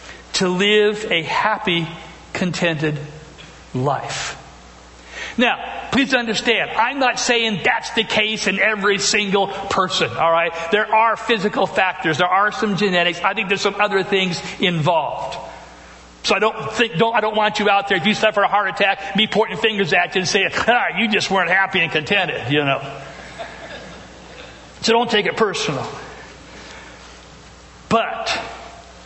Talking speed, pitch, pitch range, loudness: 155 wpm, 200 Hz, 170-215 Hz, -18 LUFS